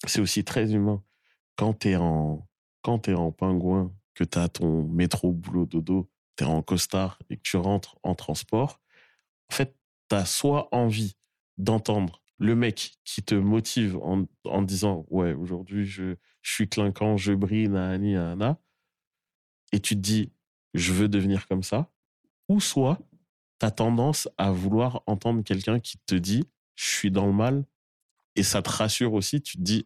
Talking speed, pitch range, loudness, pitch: 175 wpm, 95-110 Hz, -27 LUFS, 100 Hz